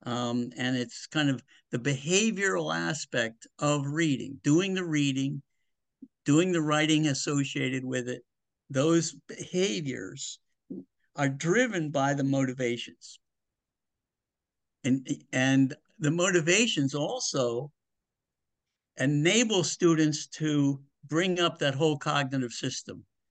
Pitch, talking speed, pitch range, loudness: 145 Hz, 105 wpm, 130-165 Hz, -28 LUFS